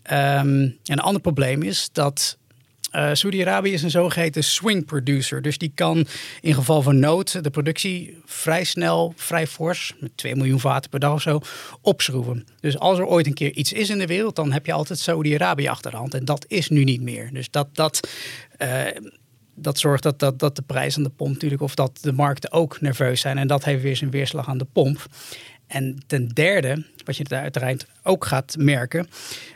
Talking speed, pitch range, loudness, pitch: 205 wpm, 135-160 Hz, -22 LUFS, 145 Hz